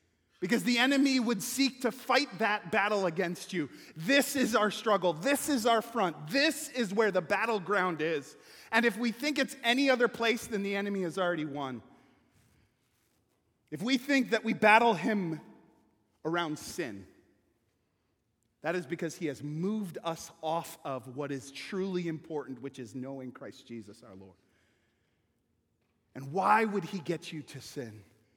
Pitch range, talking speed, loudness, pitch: 135-225 Hz, 160 wpm, -30 LUFS, 180 Hz